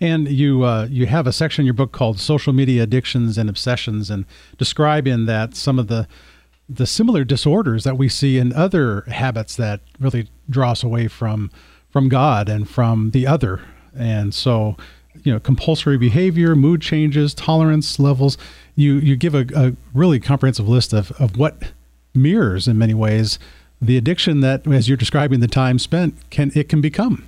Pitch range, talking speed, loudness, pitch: 110-145 Hz, 180 wpm, -17 LUFS, 130 Hz